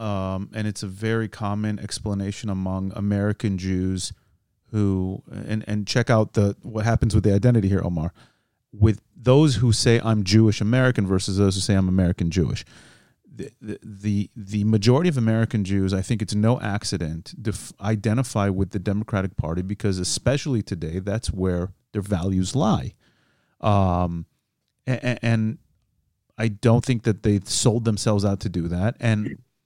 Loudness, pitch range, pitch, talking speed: -23 LUFS, 95-110 Hz, 105 Hz, 160 wpm